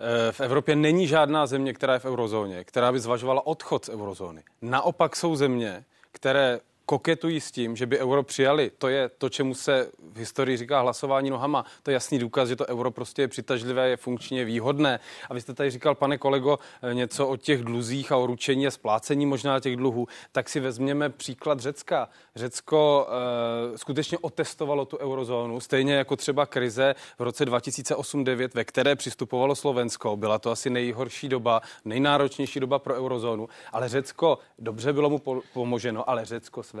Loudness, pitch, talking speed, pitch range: -26 LUFS, 130 Hz, 180 wpm, 120-140 Hz